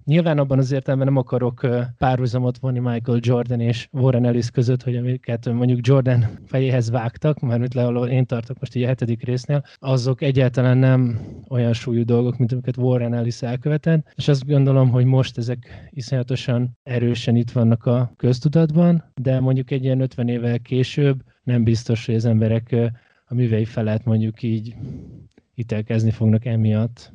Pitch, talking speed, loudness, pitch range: 125 Hz, 160 wpm, -20 LUFS, 120-130 Hz